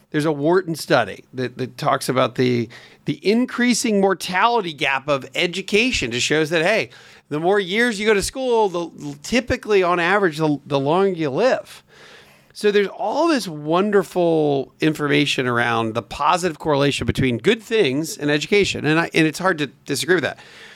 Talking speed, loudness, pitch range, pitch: 170 wpm, -19 LUFS, 145-200 Hz, 165 Hz